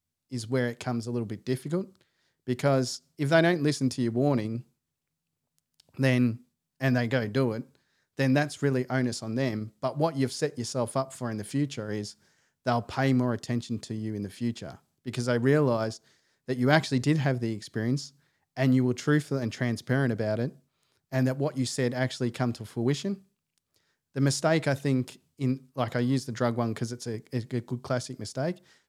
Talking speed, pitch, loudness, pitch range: 195 wpm, 130 Hz, -29 LUFS, 120-135 Hz